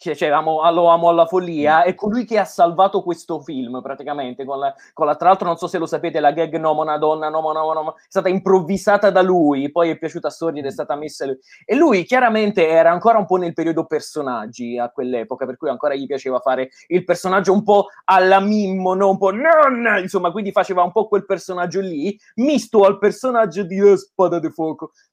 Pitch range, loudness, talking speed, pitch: 155-195 Hz, -18 LUFS, 220 wpm, 175 Hz